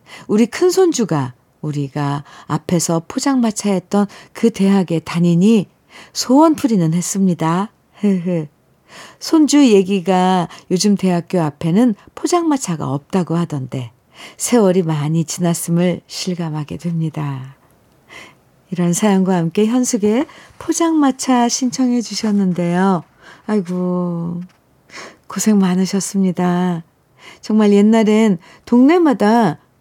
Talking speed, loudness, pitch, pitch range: 235 characters per minute, -16 LUFS, 185 Hz, 165-220 Hz